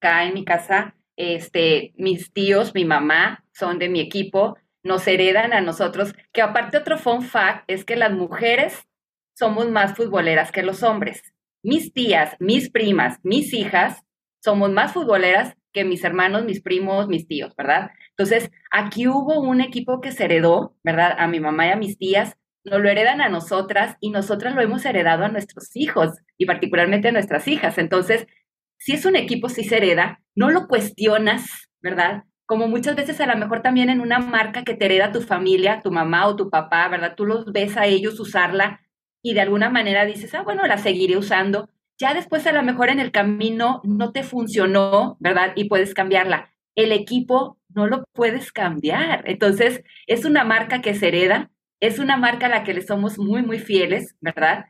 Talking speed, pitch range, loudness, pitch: 190 wpm, 185-230 Hz, -19 LUFS, 205 Hz